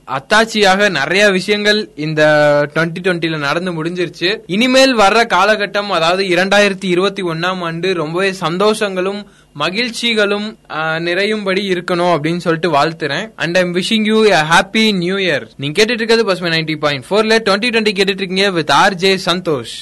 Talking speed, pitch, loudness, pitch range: 125 wpm, 185 Hz, -14 LUFS, 165-210 Hz